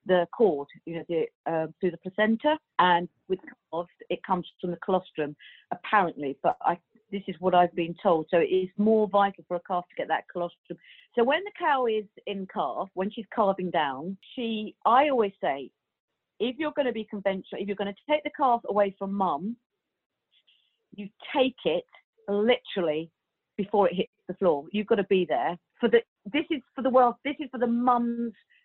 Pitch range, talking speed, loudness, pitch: 180-240 Hz, 200 wpm, -27 LUFS, 205 Hz